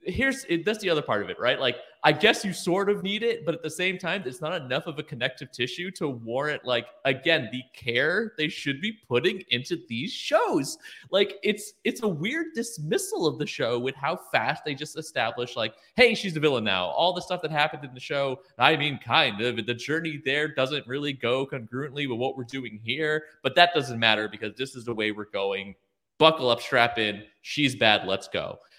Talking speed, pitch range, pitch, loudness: 220 wpm, 120-180 Hz, 150 Hz, -26 LUFS